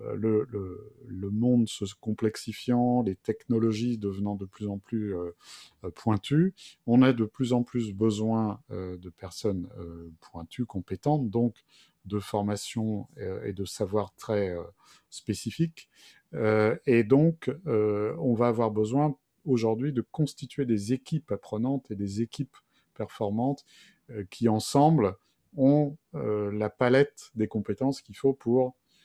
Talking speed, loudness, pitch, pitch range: 140 wpm, -28 LUFS, 110 Hz, 105-130 Hz